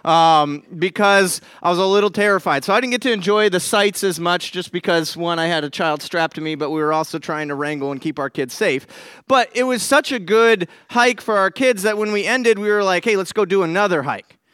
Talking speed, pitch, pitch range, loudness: 255 wpm, 195 Hz, 165-215 Hz, -18 LUFS